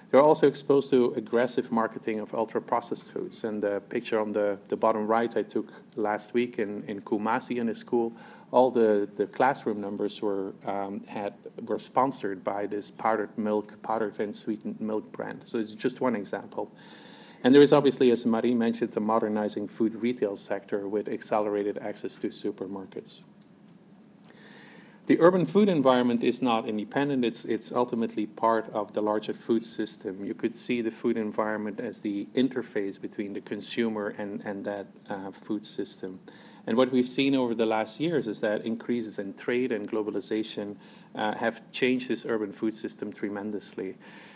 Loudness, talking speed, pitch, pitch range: -28 LUFS, 170 wpm, 115 Hz, 105-125 Hz